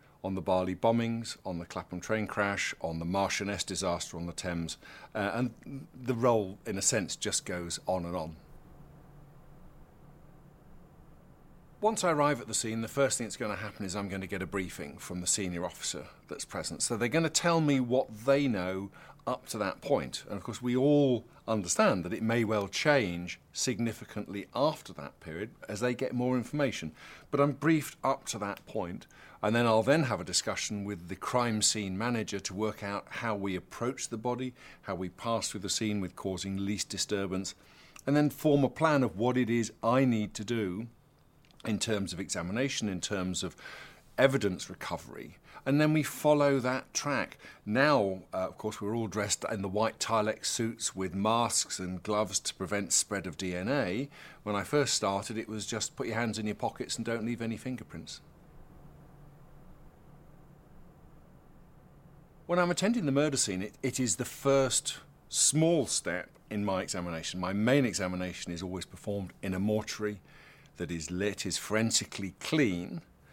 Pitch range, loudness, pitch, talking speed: 95-125 Hz, -31 LUFS, 110 Hz, 180 wpm